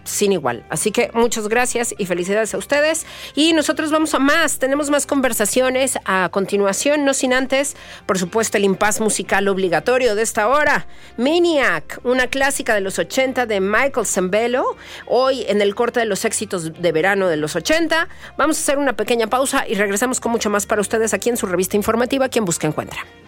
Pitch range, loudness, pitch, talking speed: 200-270 Hz, -18 LUFS, 230 Hz, 190 wpm